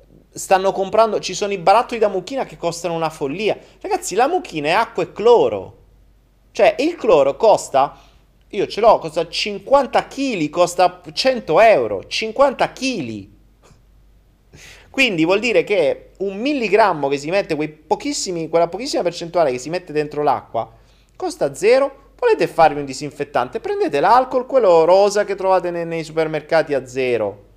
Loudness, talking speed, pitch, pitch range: -18 LUFS, 150 wpm, 190 Hz, 160-265 Hz